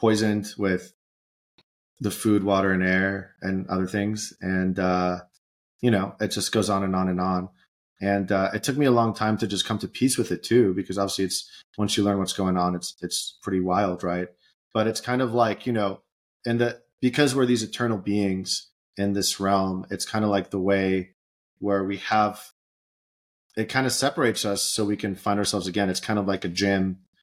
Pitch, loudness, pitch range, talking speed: 100 Hz, -25 LUFS, 95-110 Hz, 210 wpm